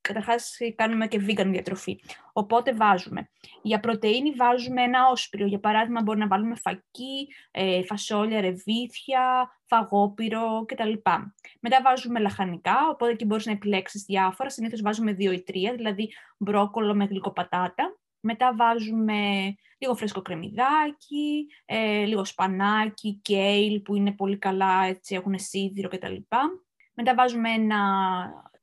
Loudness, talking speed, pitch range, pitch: -25 LUFS, 130 wpm, 195-235 Hz, 215 Hz